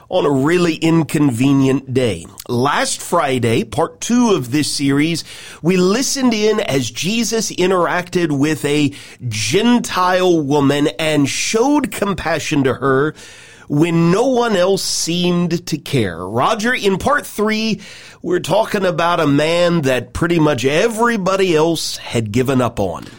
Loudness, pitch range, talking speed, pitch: -16 LUFS, 140-190 Hz, 135 wpm, 165 Hz